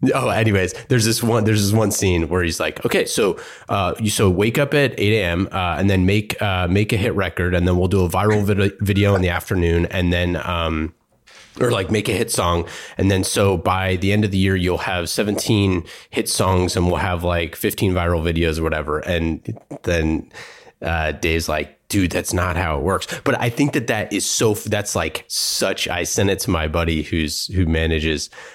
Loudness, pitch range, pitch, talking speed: -19 LUFS, 85-105 Hz, 95 Hz, 220 wpm